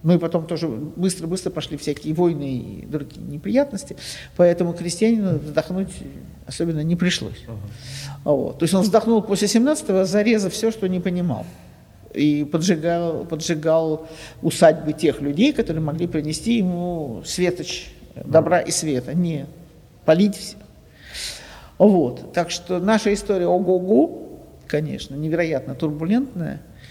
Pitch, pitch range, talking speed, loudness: 170 Hz, 155-190 Hz, 125 wpm, -21 LUFS